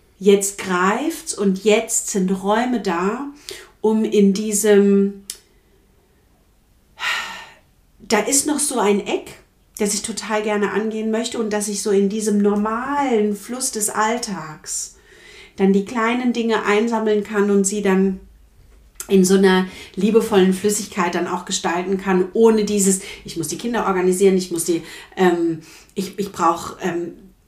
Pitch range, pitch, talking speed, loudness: 195-220 Hz, 205 Hz, 140 wpm, -19 LUFS